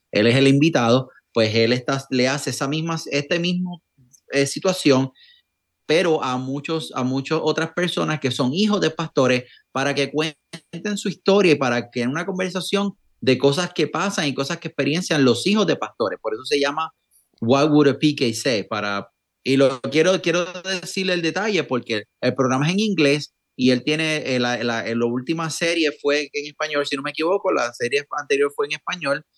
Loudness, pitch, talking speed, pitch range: -21 LUFS, 150 Hz, 195 wpm, 130-175 Hz